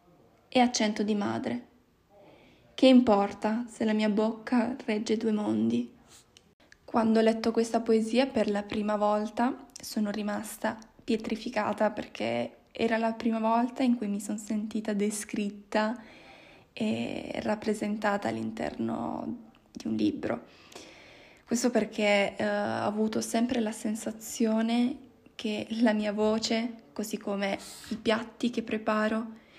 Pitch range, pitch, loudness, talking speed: 210-230 Hz, 220 Hz, -29 LUFS, 120 wpm